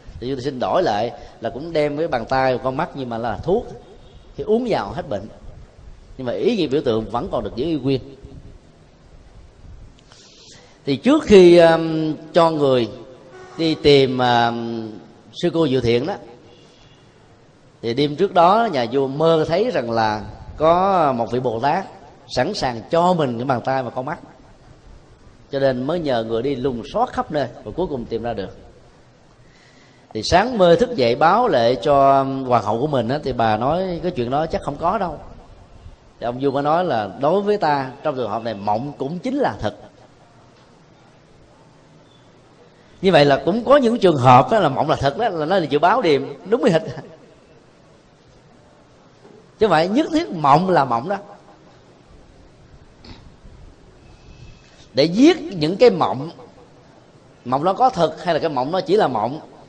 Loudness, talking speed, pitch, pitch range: -18 LUFS, 180 wpm, 135 Hz, 115-165 Hz